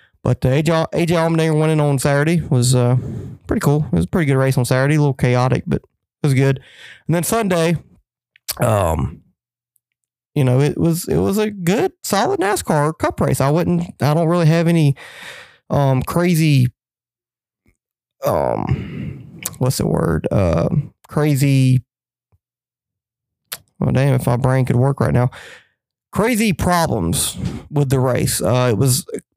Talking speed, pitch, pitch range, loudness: 150 wpm, 135 Hz, 125-165 Hz, -17 LUFS